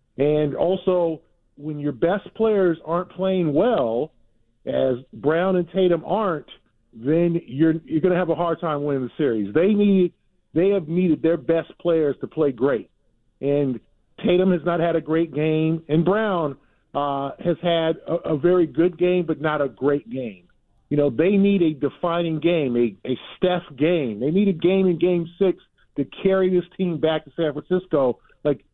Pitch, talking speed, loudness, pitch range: 165 Hz, 180 wpm, -22 LUFS, 145-180 Hz